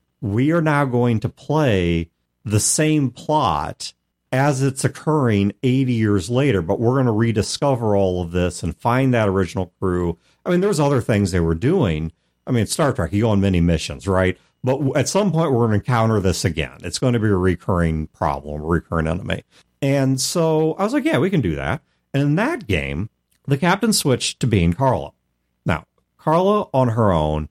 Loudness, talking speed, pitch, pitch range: -20 LUFS, 200 wpm, 110 Hz, 90-140 Hz